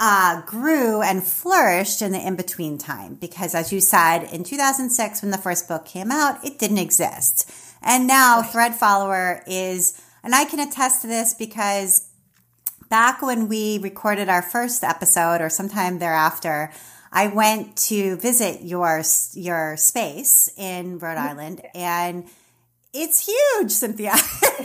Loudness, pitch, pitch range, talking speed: -19 LUFS, 195 Hz, 175-230 Hz, 145 wpm